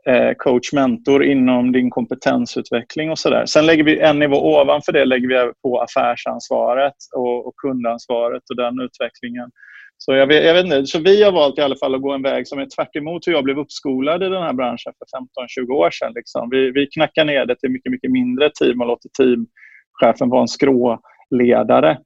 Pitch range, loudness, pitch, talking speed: 125-150 Hz, -17 LUFS, 135 Hz, 200 wpm